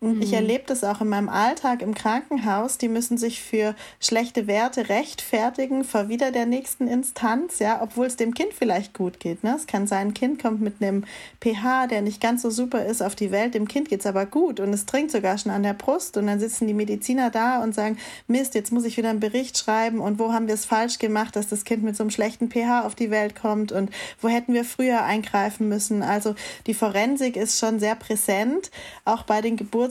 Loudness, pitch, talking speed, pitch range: -24 LUFS, 225 Hz, 230 wpm, 210-245 Hz